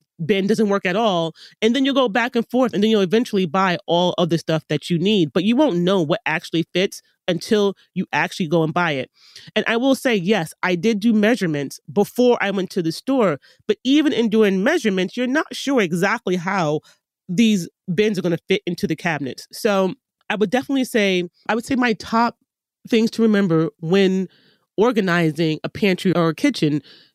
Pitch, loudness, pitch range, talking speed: 195 Hz, -20 LUFS, 175-225 Hz, 205 wpm